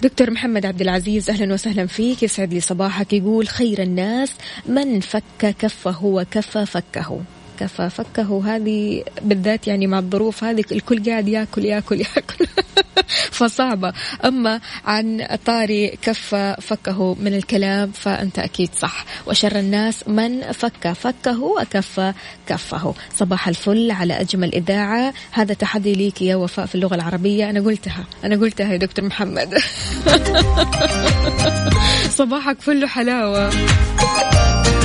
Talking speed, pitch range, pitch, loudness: 125 wpm, 195-225 Hz, 210 Hz, -19 LUFS